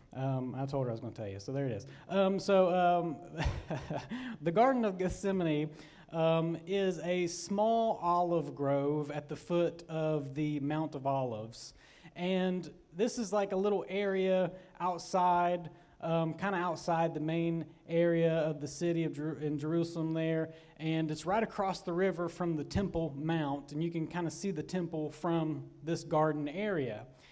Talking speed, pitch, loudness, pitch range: 175 wpm, 165 Hz, -34 LUFS, 150-180 Hz